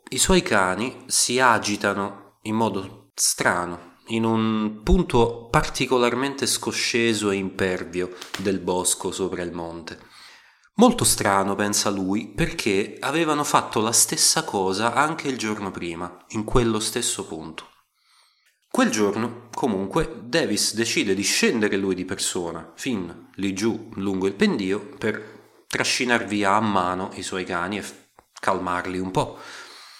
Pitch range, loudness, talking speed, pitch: 95-115 Hz, -23 LUFS, 135 wpm, 105 Hz